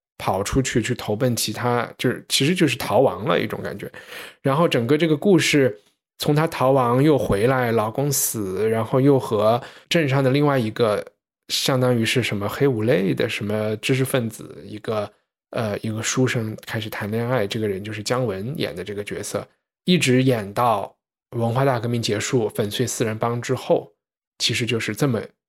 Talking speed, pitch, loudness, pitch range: 270 characters per minute, 120 Hz, -21 LUFS, 110-135 Hz